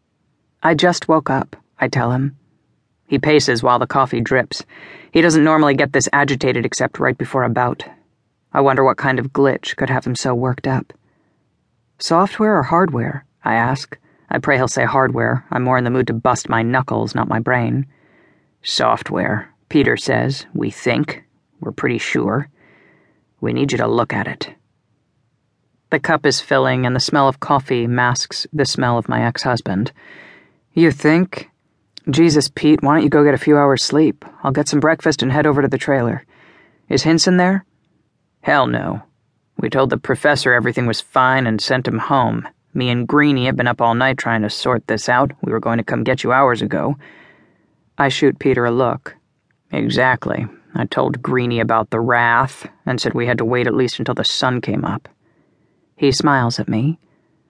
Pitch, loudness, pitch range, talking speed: 135 Hz, -17 LUFS, 125-150 Hz, 185 wpm